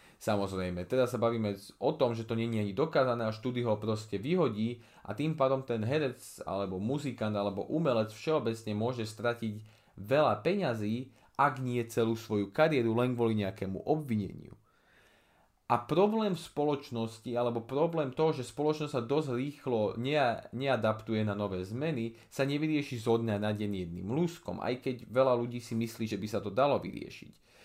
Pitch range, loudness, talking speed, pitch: 110-135 Hz, -32 LUFS, 165 wpm, 115 Hz